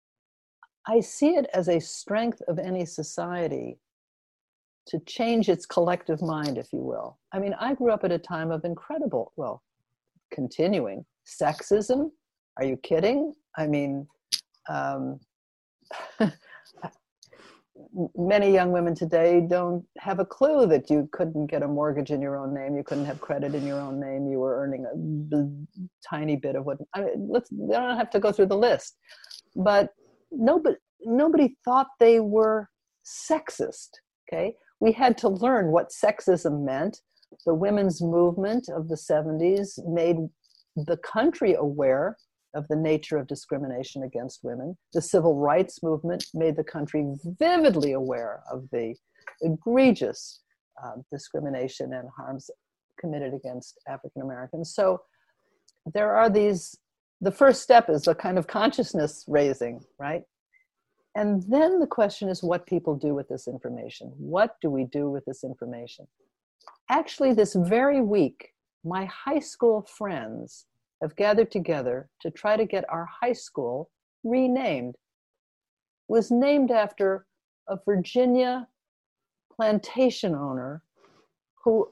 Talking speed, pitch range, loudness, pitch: 140 wpm, 150-225 Hz, -26 LUFS, 175 Hz